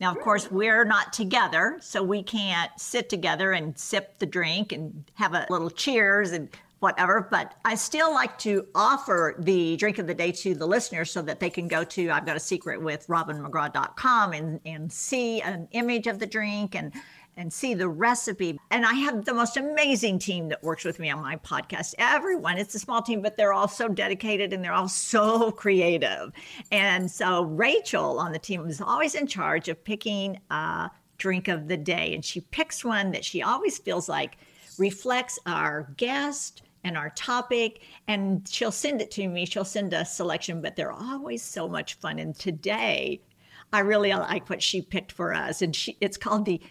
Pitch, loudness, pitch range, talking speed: 195 Hz, -26 LUFS, 170-220 Hz, 195 wpm